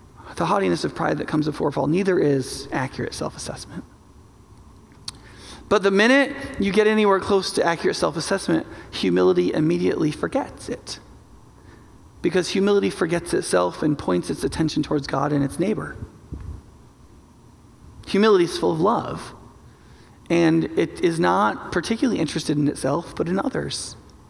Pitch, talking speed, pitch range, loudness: 155 Hz, 140 wpm, 120-195 Hz, -22 LUFS